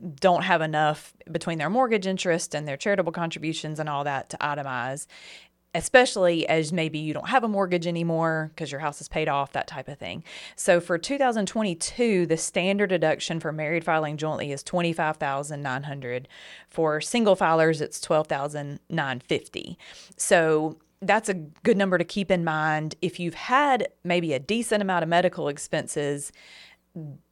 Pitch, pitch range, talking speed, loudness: 165 Hz, 155-185 Hz, 155 wpm, -25 LUFS